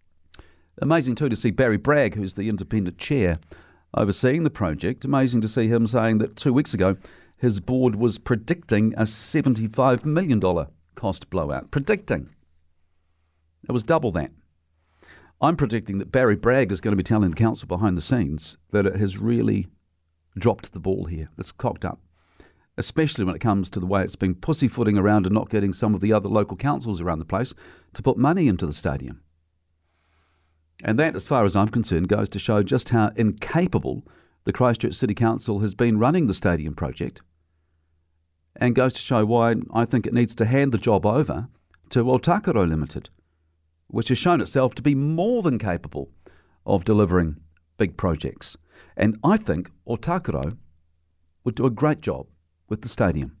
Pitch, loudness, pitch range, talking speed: 105 Hz, -23 LUFS, 85-120 Hz, 175 wpm